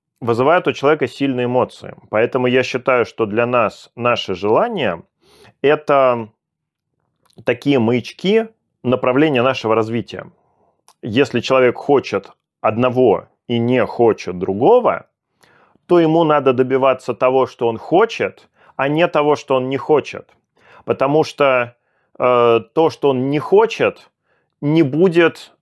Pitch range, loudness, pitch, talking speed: 120-150 Hz, -16 LUFS, 130 Hz, 120 wpm